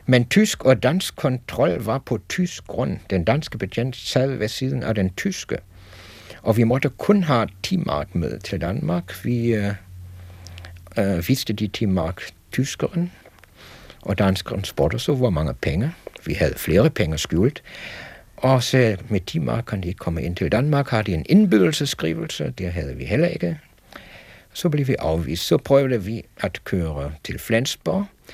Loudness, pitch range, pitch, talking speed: -22 LUFS, 90-130 Hz, 110 Hz, 160 wpm